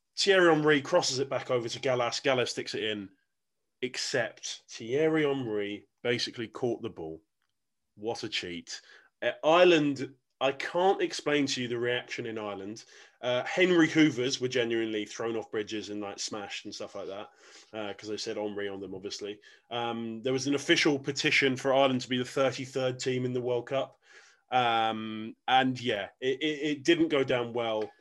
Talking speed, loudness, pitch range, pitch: 180 wpm, -29 LUFS, 115-145 Hz, 125 Hz